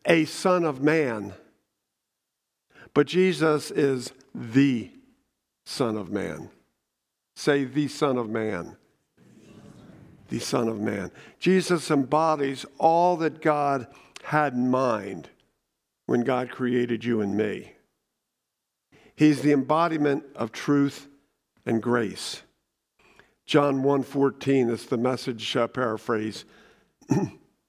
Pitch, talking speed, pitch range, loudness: 140 Hz, 110 wpm, 120-150 Hz, -25 LUFS